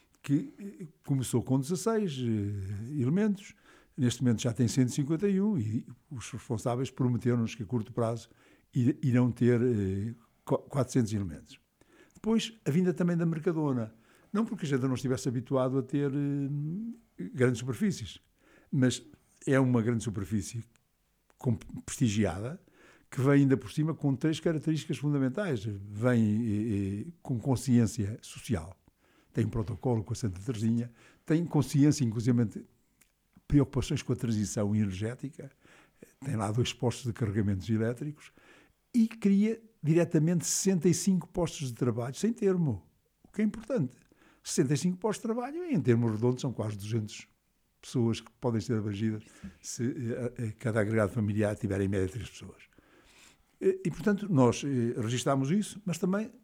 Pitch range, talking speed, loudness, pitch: 115-160 Hz, 140 wpm, -30 LUFS, 125 Hz